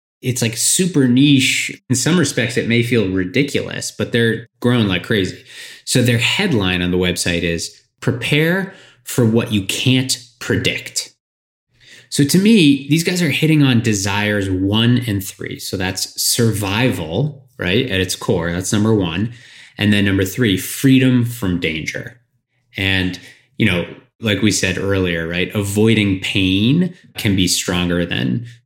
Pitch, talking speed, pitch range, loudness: 115 Hz, 150 wpm, 95-130 Hz, -16 LUFS